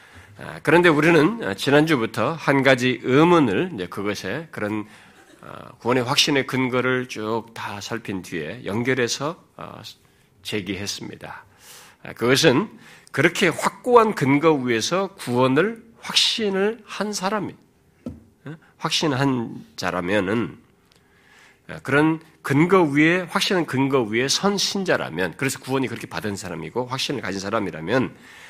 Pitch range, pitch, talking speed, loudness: 115-165 Hz, 135 Hz, 255 characters per minute, -21 LUFS